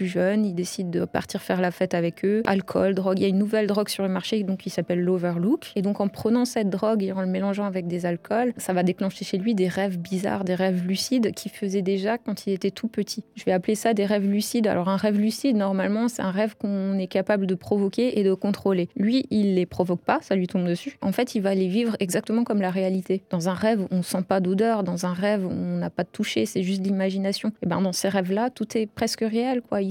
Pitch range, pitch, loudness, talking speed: 185-215 Hz, 195 Hz, -25 LUFS, 260 wpm